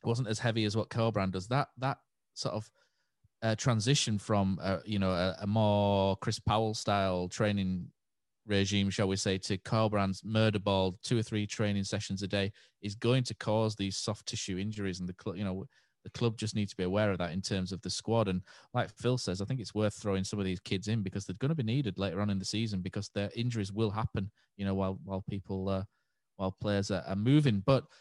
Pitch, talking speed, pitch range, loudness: 105 Hz, 235 wpm, 95-110 Hz, -33 LUFS